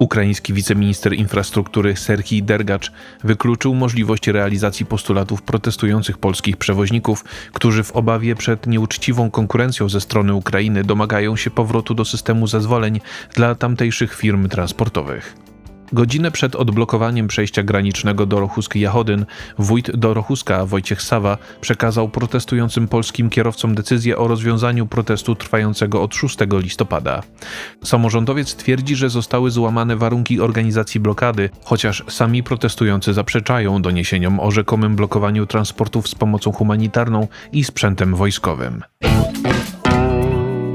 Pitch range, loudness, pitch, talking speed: 105-120 Hz, -17 LUFS, 110 Hz, 115 wpm